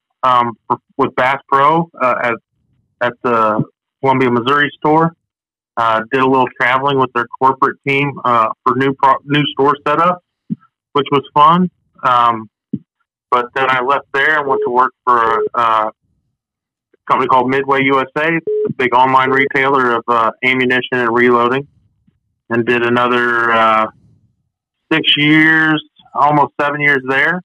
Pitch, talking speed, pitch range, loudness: 130 Hz, 150 wpm, 120-145 Hz, -13 LUFS